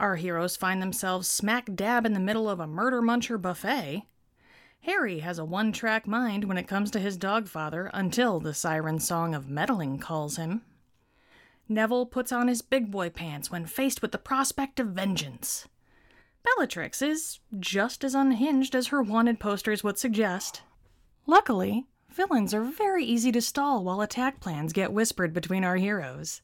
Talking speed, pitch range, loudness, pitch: 170 wpm, 180-245 Hz, -28 LUFS, 210 Hz